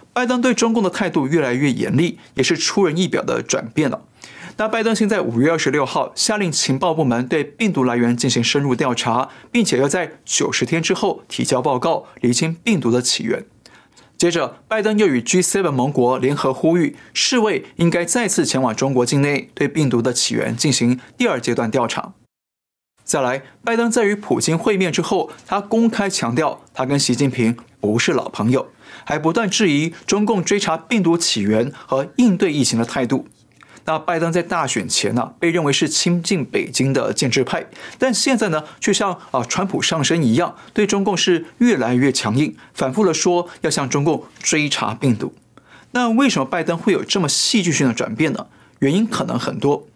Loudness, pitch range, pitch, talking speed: -18 LUFS, 130-205 Hz, 165 Hz, 280 characters per minute